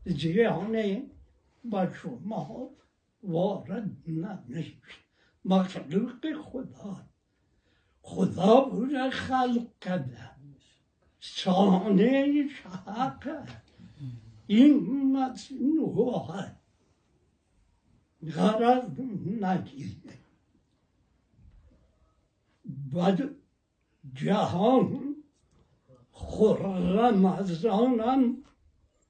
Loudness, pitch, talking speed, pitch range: -27 LUFS, 200 Hz, 45 wpm, 165-250 Hz